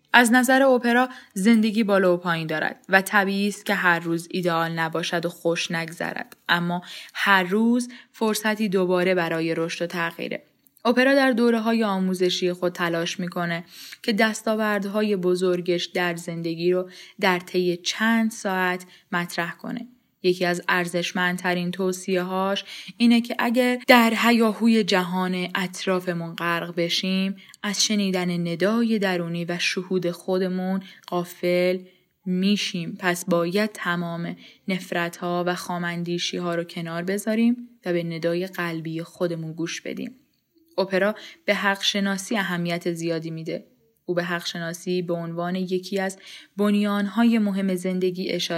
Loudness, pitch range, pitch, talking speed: -23 LUFS, 175-205 Hz, 185 Hz, 135 wpm